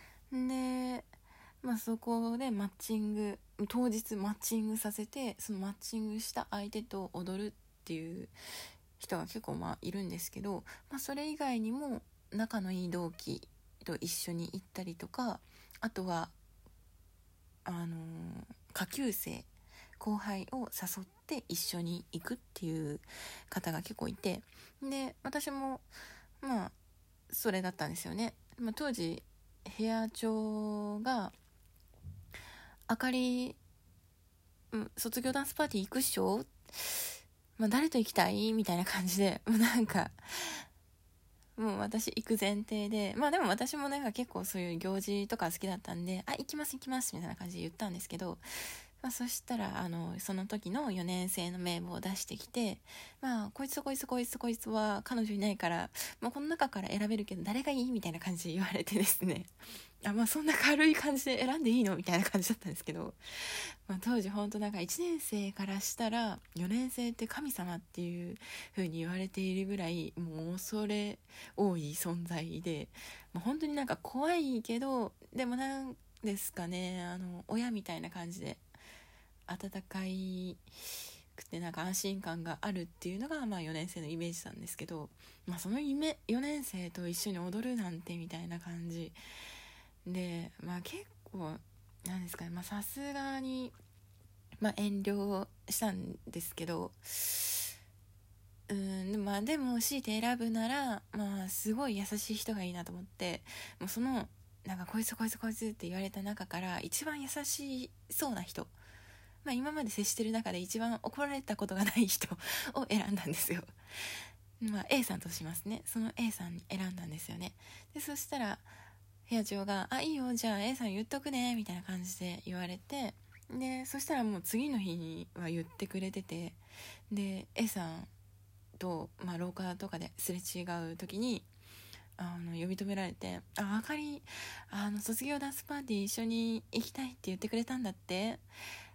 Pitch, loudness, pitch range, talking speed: 200 Hz, -37 LUFS, 175-230 Hz, 310 characters per minute